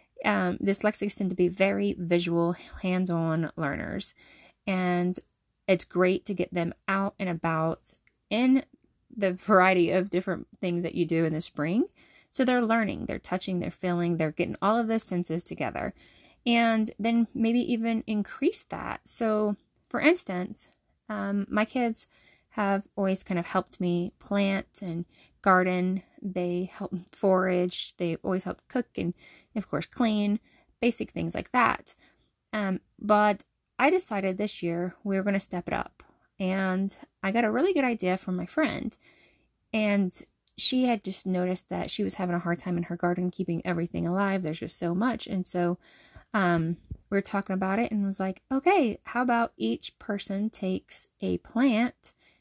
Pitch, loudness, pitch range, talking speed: 190 Hz, -28 LUFS, 180-215 Hz, 165 wpm